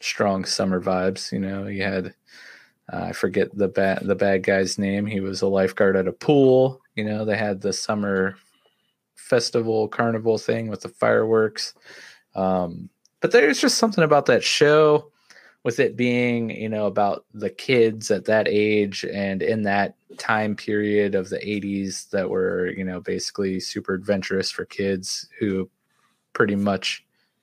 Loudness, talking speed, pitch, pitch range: -22 LUFS, 160 wpm, 100 Hz, 95-110 Hz